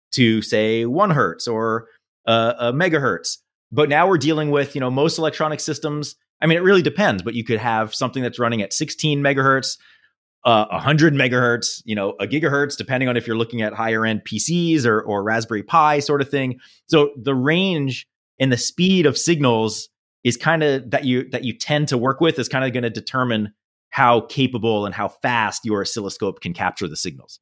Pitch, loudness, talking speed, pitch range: 125 Hz, -19 LUFS, 200 wpm, 115-150 Hz